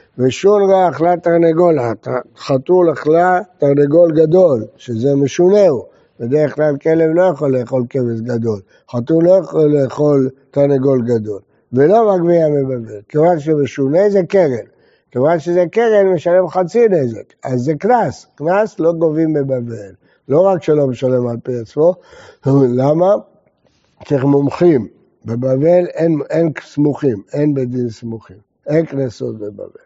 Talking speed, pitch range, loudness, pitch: 135 wpm, 130-175 Hz, -14 LUFS, 150 Hz